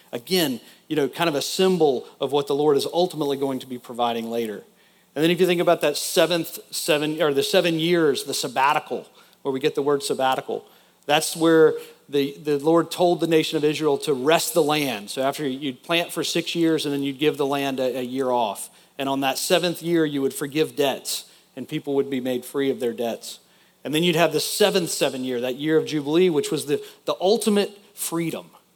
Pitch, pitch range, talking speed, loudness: 150 Hz, 135-170 Hz, 220 wpm, -22 LUFS